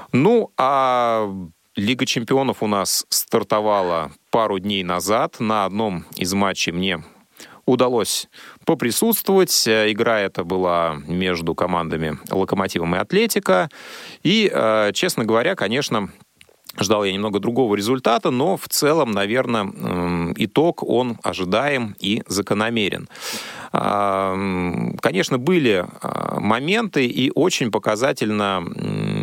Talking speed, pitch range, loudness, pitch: 100 wpm, 95-120 Hz, -20 LUFS, 105 Hz